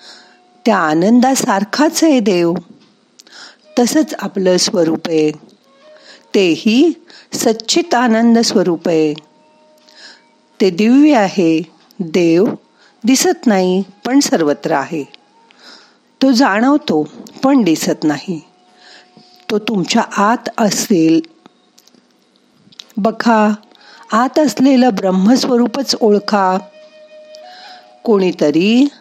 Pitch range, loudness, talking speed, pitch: 185-275 Hz, -13 LUFS, 80 wpm, 225 Hz